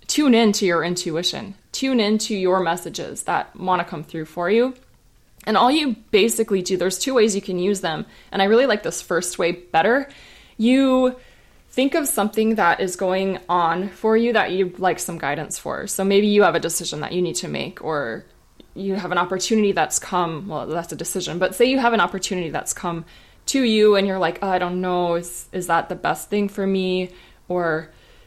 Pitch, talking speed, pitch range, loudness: 190 Hz, 210 wpm, 175-215 Hz, -21 LUFS